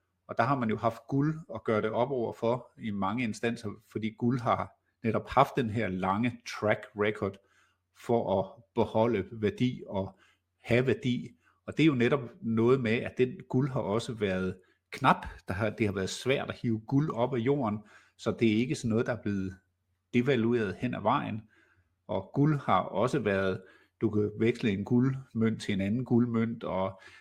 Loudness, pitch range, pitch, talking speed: -30 LUFS, 100-120 Hz, 115 Hz, 190 wpm